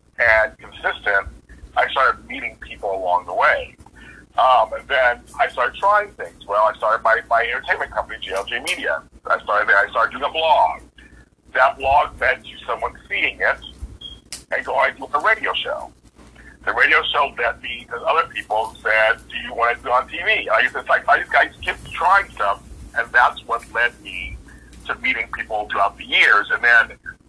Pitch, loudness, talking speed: 75 Hz, -19 LUFS, 190 wpm